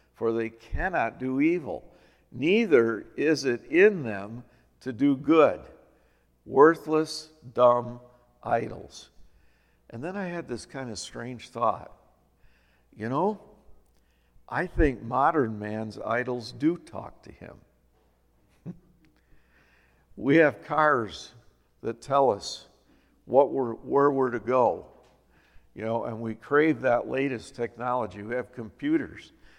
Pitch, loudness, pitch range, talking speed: 115 Hz, -26 LUFS, 80-135 Hz, 120 wpm